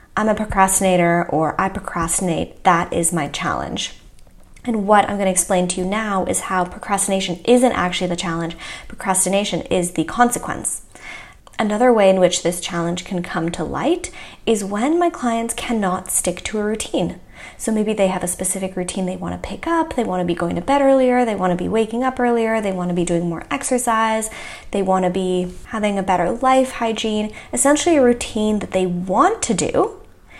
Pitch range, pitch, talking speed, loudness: 180-230 Hz, 195 Hz, 195 wpm, -19 LUFS